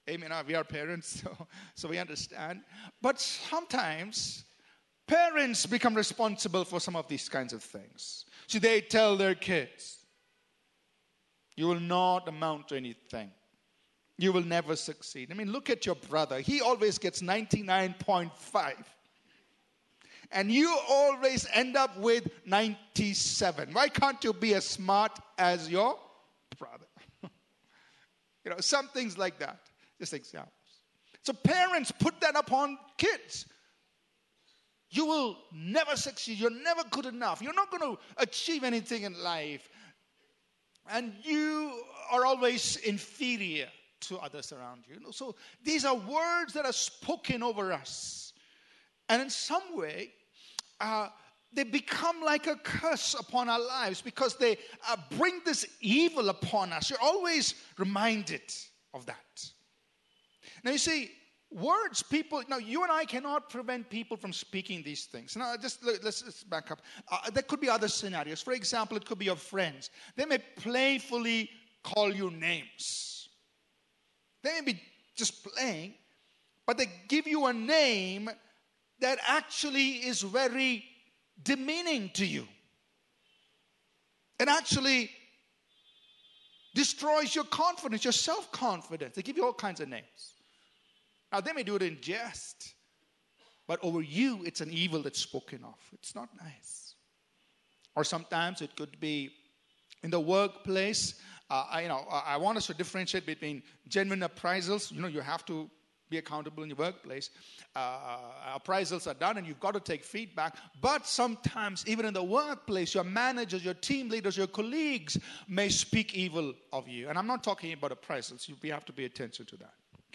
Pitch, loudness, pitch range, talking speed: 215 Hz, -32 LUFS, 175-265 Hz, 150 wpm